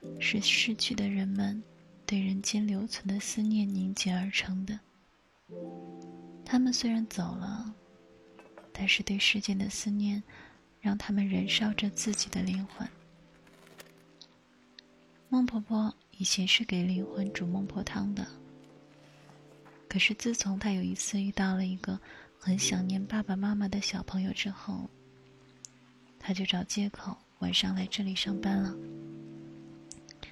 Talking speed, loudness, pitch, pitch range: 190 characters per minute, -31 LUFS, 195 Hz, 180-205 Hz